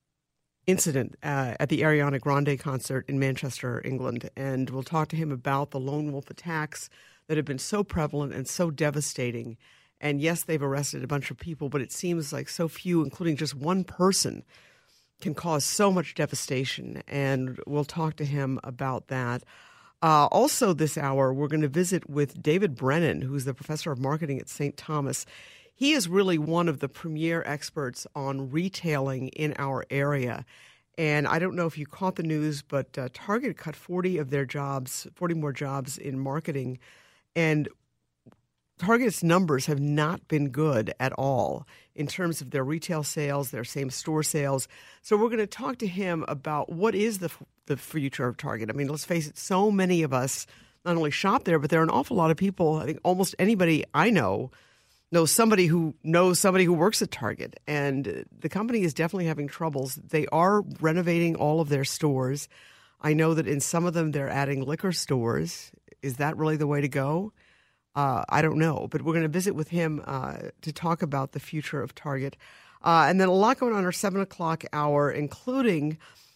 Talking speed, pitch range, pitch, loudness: 195 wpm, 140-170 Hz, 150 Hz, -27 LUFS